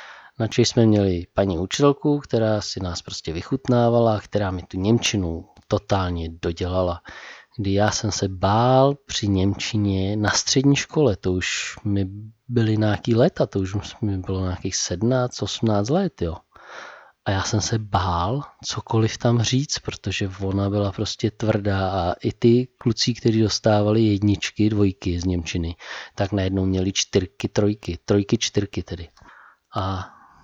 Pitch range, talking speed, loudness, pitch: 95-115 Hz, 145 wpm, -22 LUFS, 105 Hz